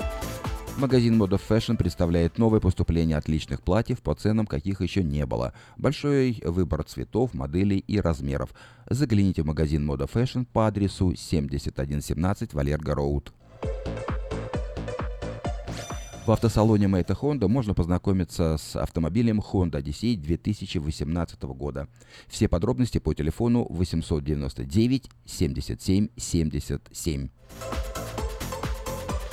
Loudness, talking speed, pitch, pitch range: -27 LUFS, 95 wpm, 90 Hz, 75-110 Hz